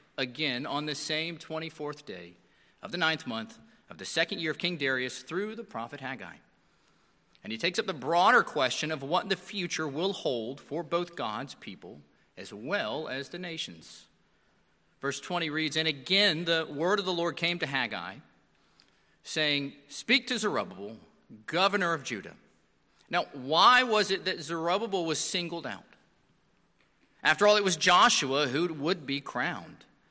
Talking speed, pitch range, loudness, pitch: 165 wpm, 145-180 Hz, -29 LUFS, 160 Hz